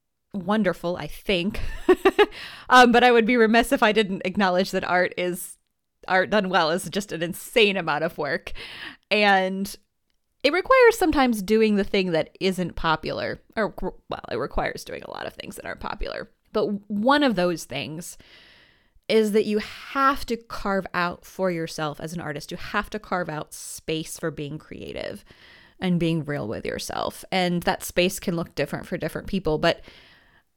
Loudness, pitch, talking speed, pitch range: -23 LUFS, 190 Hz, 175 wpm, 170-220 Hz